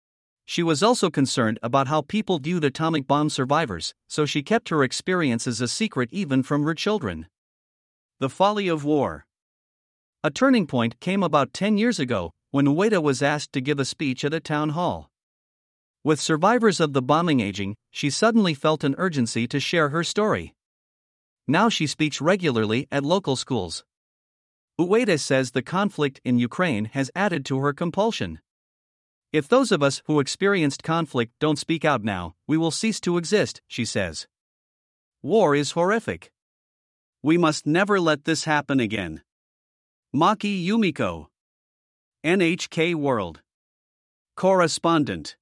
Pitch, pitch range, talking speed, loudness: 150 Hz, 130-175 Hz, 150 wpm, -23 LUFS